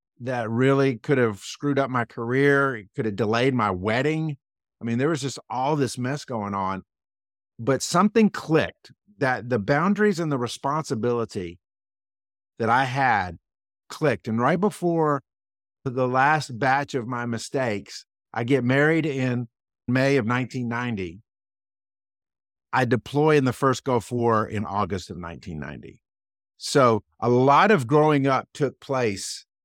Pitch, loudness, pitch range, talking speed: 125 Hz, -23 LUFS, 105-140 Hz, 145 wpm